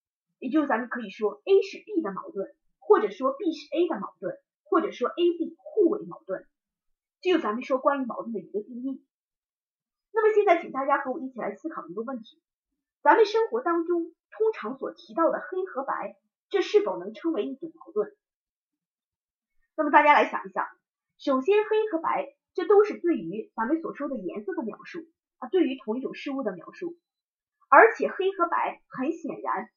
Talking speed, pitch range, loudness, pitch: 275 characters per minute, 270-375 Hz, -26 LUFS, 330 Hz